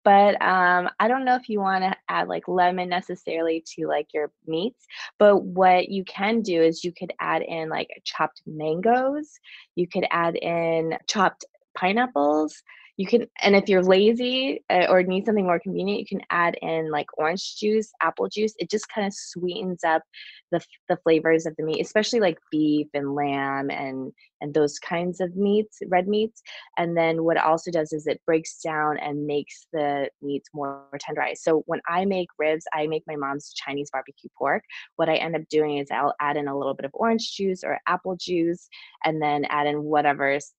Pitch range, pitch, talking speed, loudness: 150-195 Hz, 170 Hz, 195 wpm, -24 LUFS